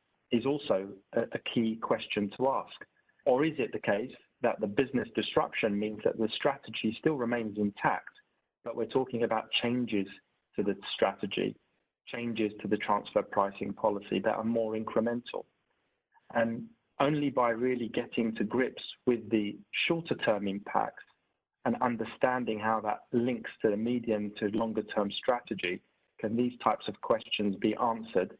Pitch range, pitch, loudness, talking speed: 105-120 Hz, 115 Hz, -32 LUFS, 150 wpm